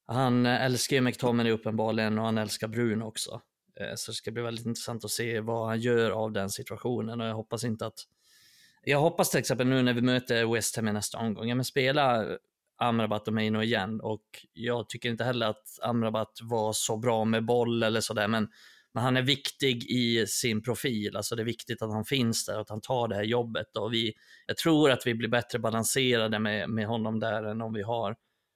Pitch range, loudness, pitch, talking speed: 110-120 Hz, -29 LUFS, 115 Hz, 220 wpm